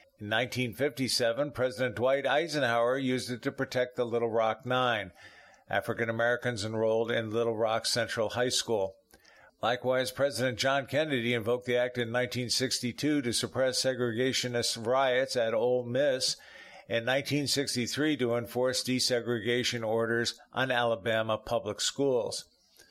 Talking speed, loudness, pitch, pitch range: 125 wpm, -30 LUFS, 125 Hz, 115-130 Hz